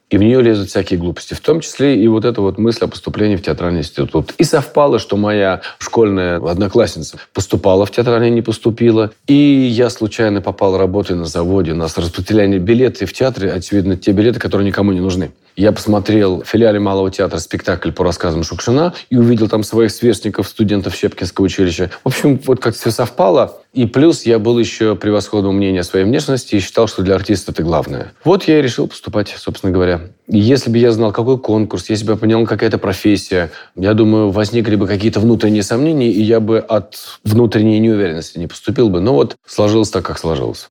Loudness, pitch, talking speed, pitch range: -14 LUFS, 105 Hz, 200 wpm, 95-115 Hz